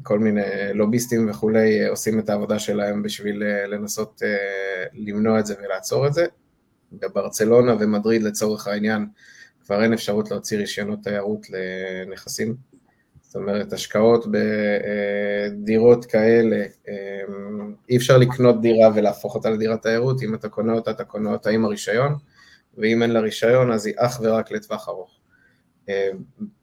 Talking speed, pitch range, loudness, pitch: 135 wpm, 100-115 Hz, -21 LUFS, 105 Hz